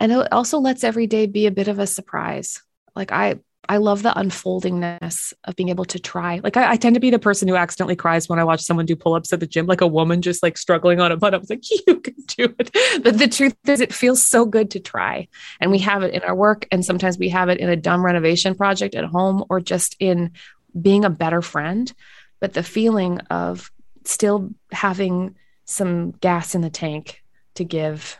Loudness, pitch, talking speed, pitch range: -19 LUFS, 185 Hz, 230 wpm, 175-220 Hz